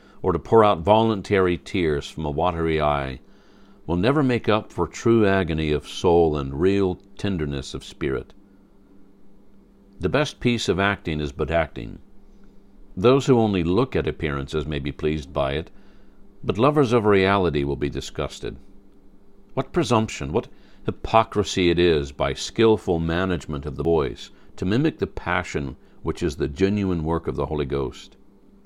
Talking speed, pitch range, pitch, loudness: 155 wpm, 75-100 Hz, 95 Hz, -23 LUFS